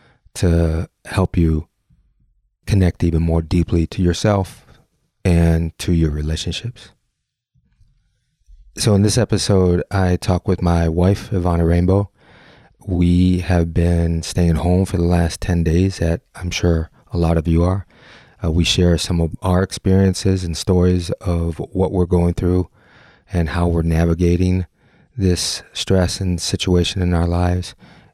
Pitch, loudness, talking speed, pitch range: 90 Hz, -18 LUFS, 145 wpm, 85-95 Hz